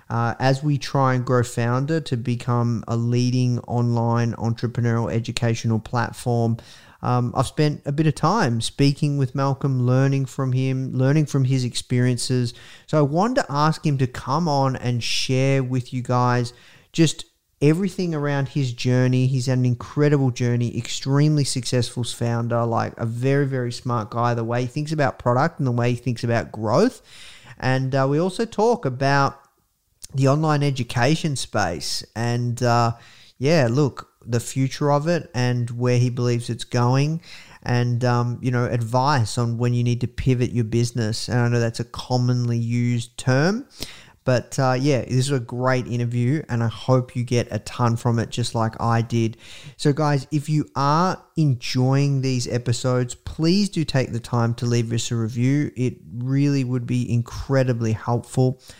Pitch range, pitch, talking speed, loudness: 120-135 Hz, 125 Hz, 170 wpm, -22 LUFS